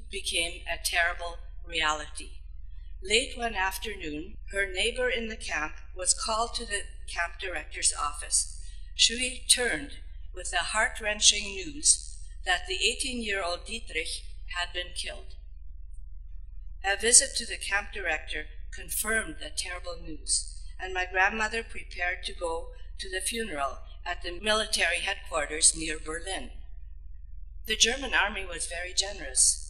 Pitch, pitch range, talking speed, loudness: 180 Hz, 135-220 Hz, 135 wpm, -28 LUFS